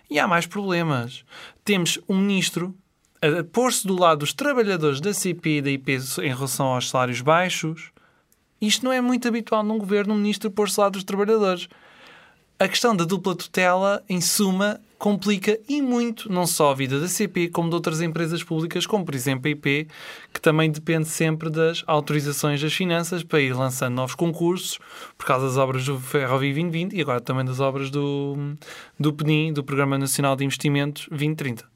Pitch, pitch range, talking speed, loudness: 165 Hz, 145-195 Hz, 185 wpm, -23 LUFS